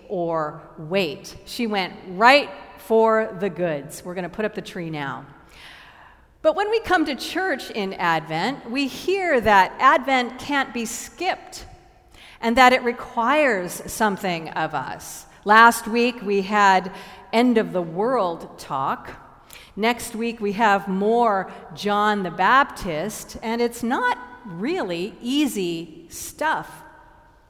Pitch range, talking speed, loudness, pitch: 190-250 Hz, 135 wpm, -21 LUFS, 220 Hz